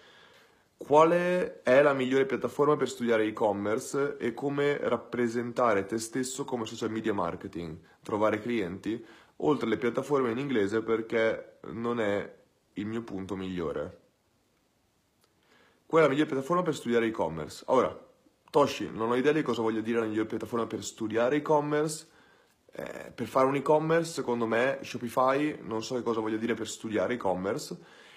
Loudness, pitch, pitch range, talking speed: -29 LUFS, 120 Hz, 110-140 Hz, 150 wpm